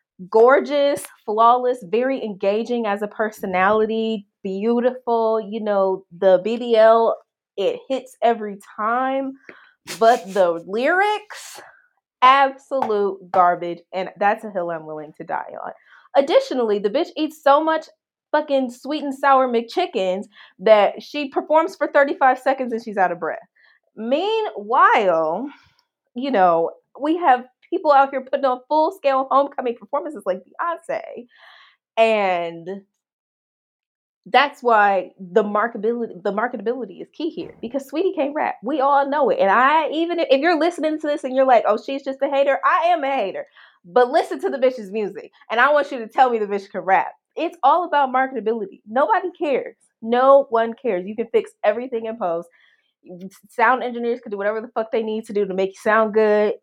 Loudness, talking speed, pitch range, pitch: -20 LUFS, 165 wpm, 210-285 Hz, 240 Hz